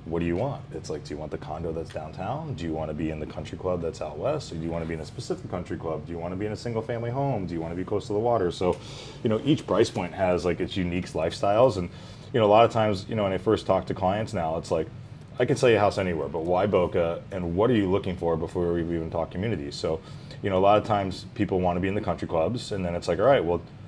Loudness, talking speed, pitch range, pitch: -27 LUFS, 320 wpm, 85-110 Hz, 95 Hz